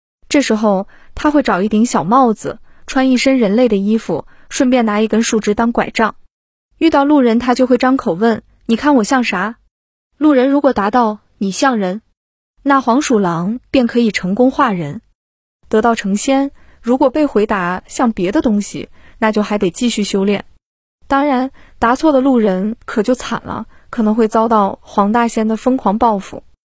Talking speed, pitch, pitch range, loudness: 245 characters per minute, 230 Hz, 210-265 Hz, -14 LUFS